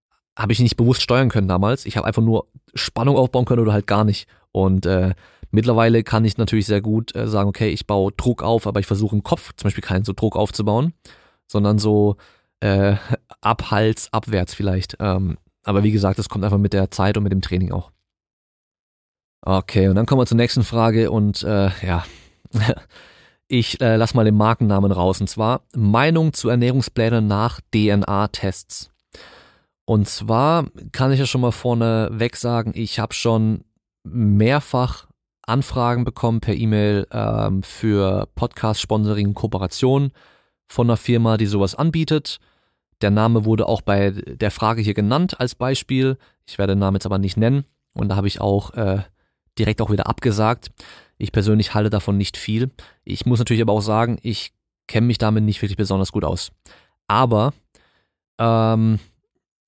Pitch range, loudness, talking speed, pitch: 100-115 Hz, -19 LUFS, 170 wpm, 110 Hz